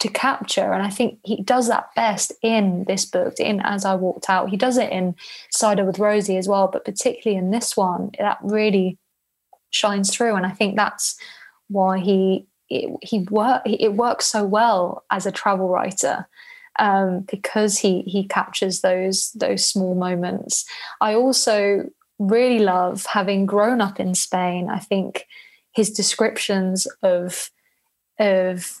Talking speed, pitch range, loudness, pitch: 160 wpm, 190-220 Hz, -20 LUFS, 200 Hz